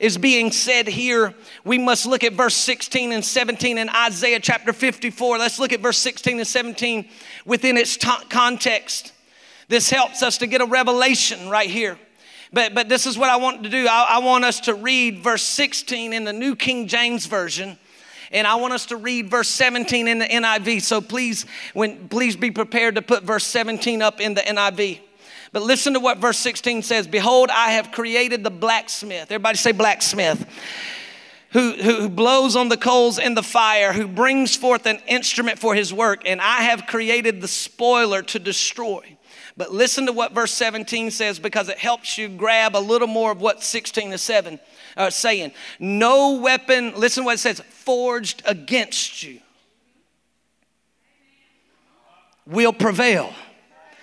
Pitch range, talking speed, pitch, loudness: 220-245 Hz, 180 wpm, 235 Hz, -19 LUFS